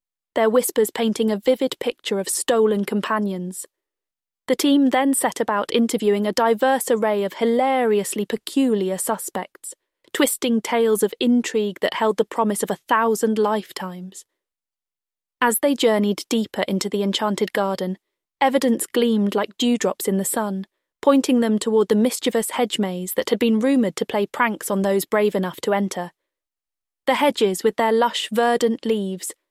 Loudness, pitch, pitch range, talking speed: -21 LUFS, 225 Hz, 205-245 Hz, 155 wpm